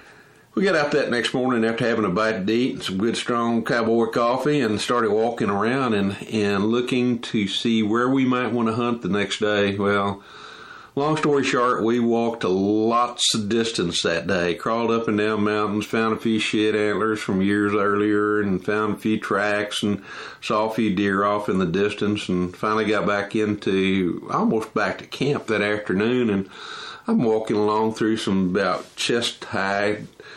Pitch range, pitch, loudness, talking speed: 105-115 Hz, 110 Hz, -22 LUFS, 190 wpm